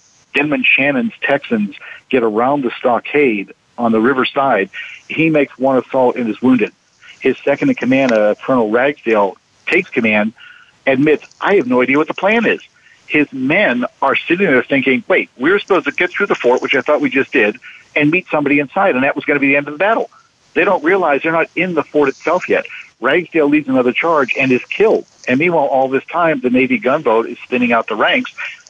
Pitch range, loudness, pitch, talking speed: 125-160 Hz, -14 LUFS, 140 Hz, 210 wpm